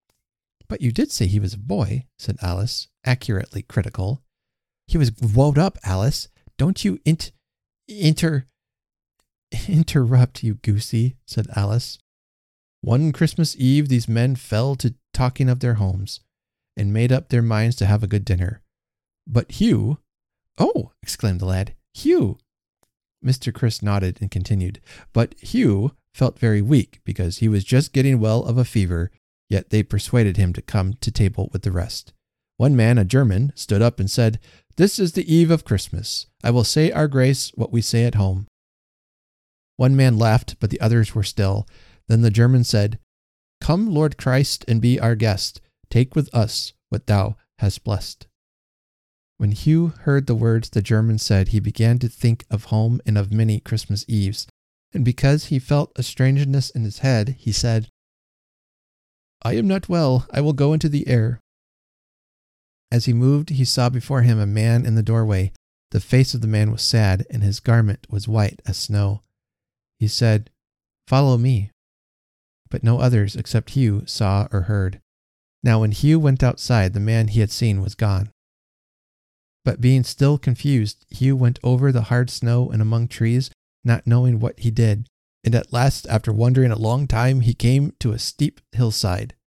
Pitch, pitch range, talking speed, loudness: 115 Hz, 105-130 Hz, 170 wpm, -20 LUFS